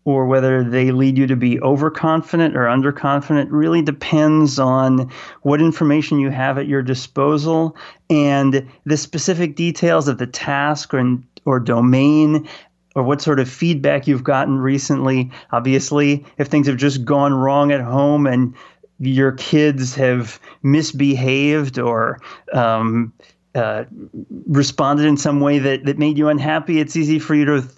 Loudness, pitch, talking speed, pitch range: -17 LUFS, 140 Hz, 150 wpm, 130-150 Hz